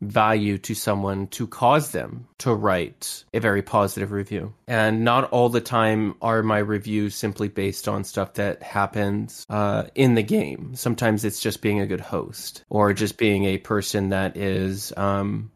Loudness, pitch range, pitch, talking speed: -23 LUFS, 100-110 Hz, 105 Hz, 175 wpm